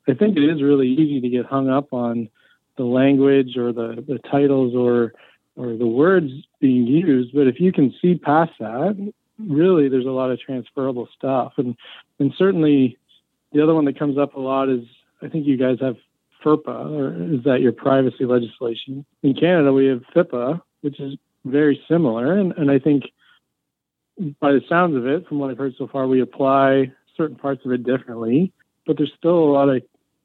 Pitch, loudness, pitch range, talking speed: 135 Hz, -19 LUFS, 130-150 Hz, 195 wpm